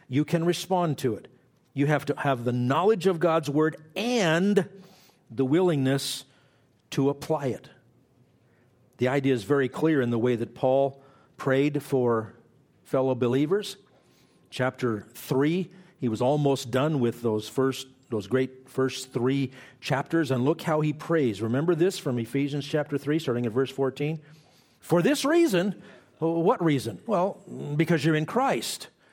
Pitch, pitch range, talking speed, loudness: 140 Hz, 130-160 Hz, 150 wpm, -26 LUFS